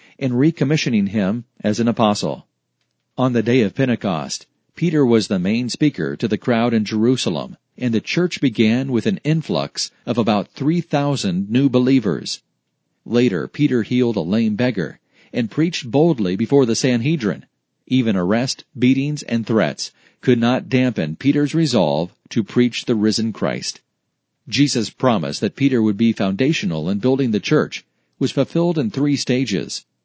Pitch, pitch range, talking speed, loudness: 130 Hz, 115-150 Hz, 150 wpm, -19 LUFS